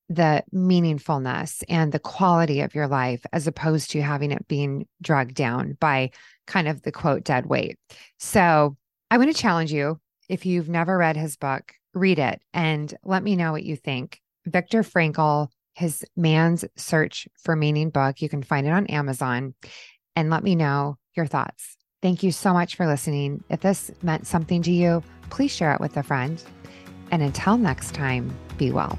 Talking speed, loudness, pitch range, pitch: 180 wpm, -23 LUFS, 145-175 Hz, 155 Hz